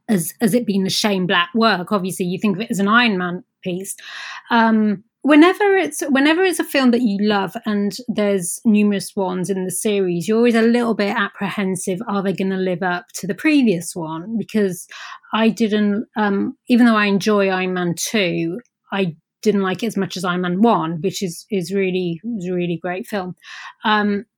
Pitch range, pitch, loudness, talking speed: 185-225 Hz, 200 Hz, -18 LUFS, 200 wpm